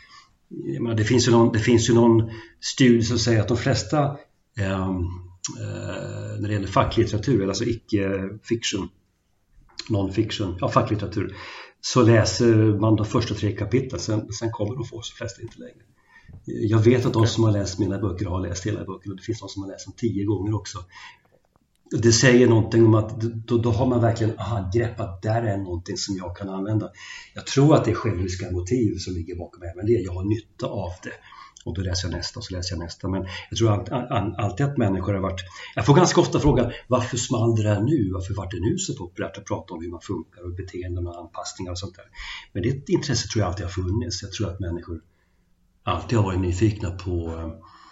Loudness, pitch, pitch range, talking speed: -23 LUFS, 105 Hz, 95-115 Hz, 215 wpm